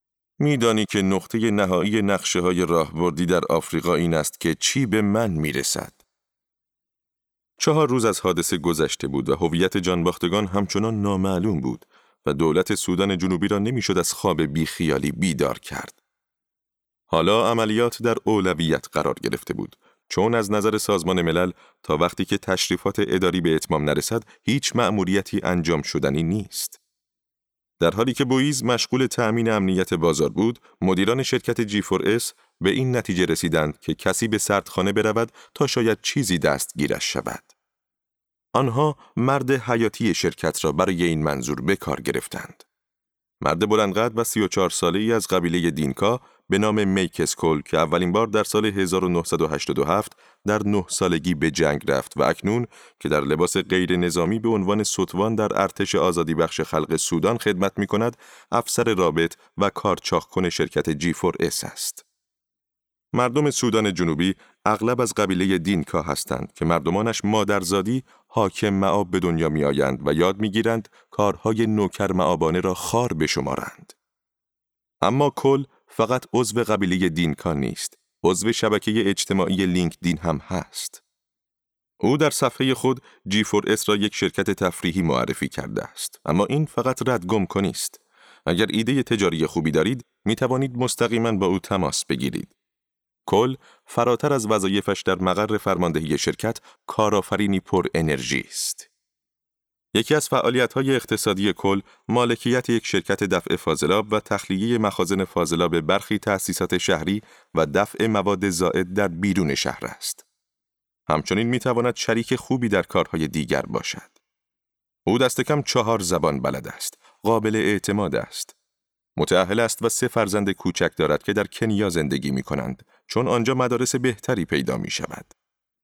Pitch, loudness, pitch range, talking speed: 100 Hz, -22 LUFS, 90-115 Hz, 145 wpm